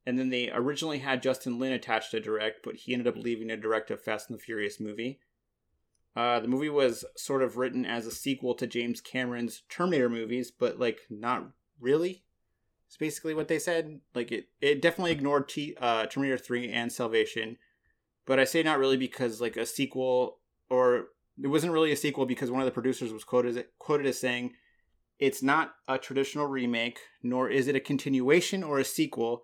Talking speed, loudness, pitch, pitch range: 195 wpm, -30 LUFS, 130 Hz, 120-140 Hz